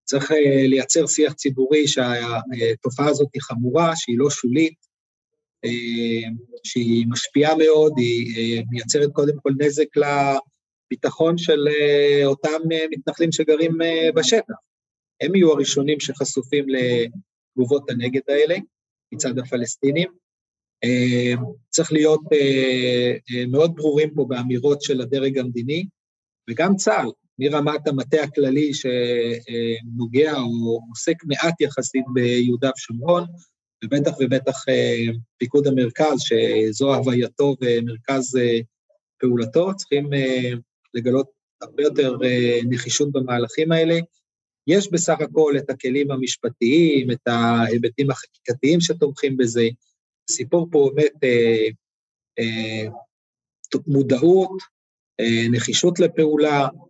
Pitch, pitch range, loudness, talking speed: 135 Hz, 120-155 Hz, -20 LUFS, 90 wpm